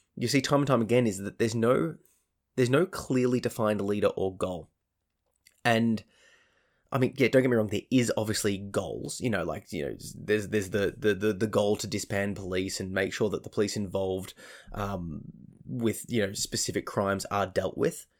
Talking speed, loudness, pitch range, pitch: 195 wpm, -29 LUFS, 95-115 Hz, 105 Hz